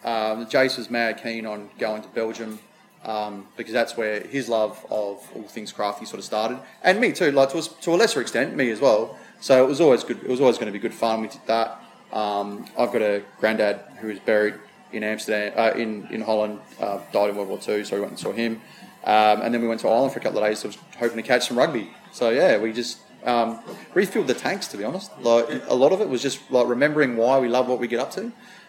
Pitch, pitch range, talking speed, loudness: 115 Hz, 105-125 Hz, 260 wpm, -23 LUFS